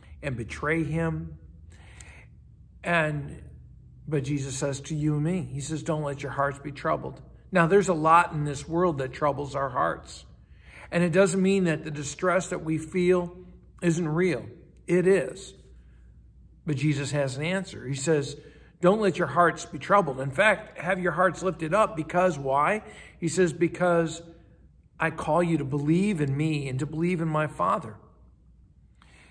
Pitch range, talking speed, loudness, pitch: 140-175 Hz, 170 wpm, -26 LUFS, 160 Hz